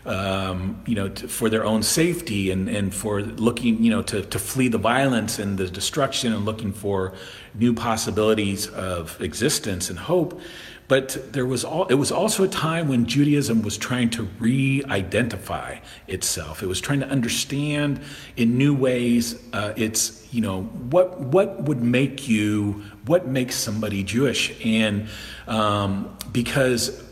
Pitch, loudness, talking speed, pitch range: 115 Hz, -23 LUFS, 155 wpm, 105-135 Hz